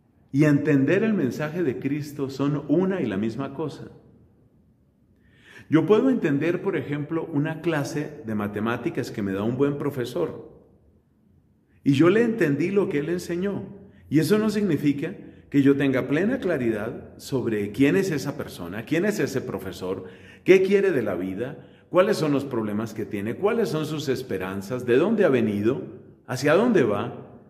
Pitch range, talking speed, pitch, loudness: 115-165 Hz, 165 wpm, 145 Hz, -24 LUFS